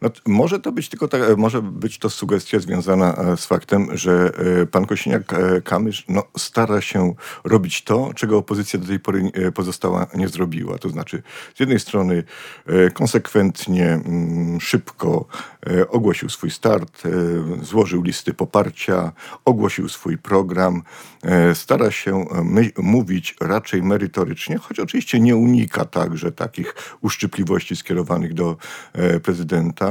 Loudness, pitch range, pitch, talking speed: -19 LUFS, 90-105 Hz, 95 Hz, 120 wpm